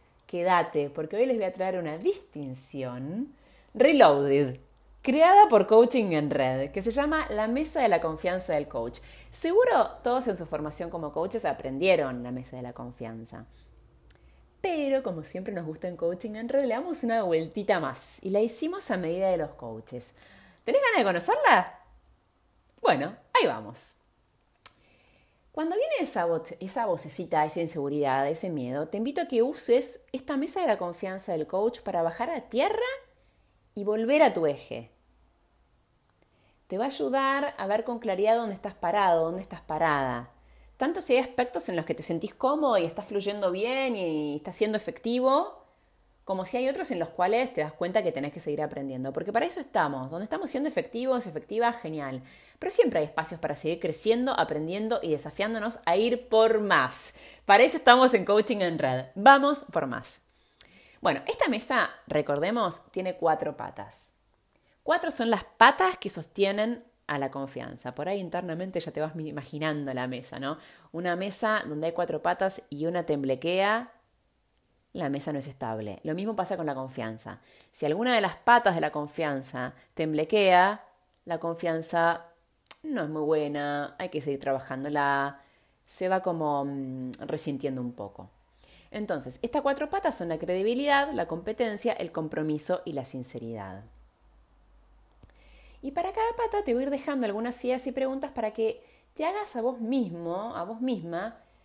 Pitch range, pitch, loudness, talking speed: 150-240 Hz, 180 Hz, -27 LUFS, 170 wpm